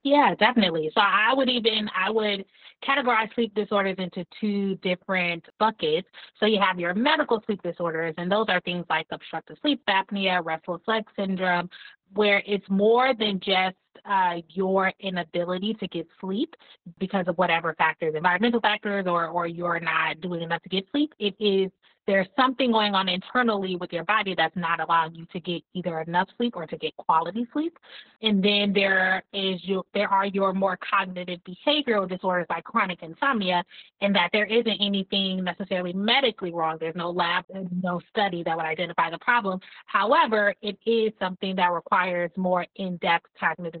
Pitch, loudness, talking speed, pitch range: 190 Hz, -25 LUFS, 175 wpm, 175-210 Hz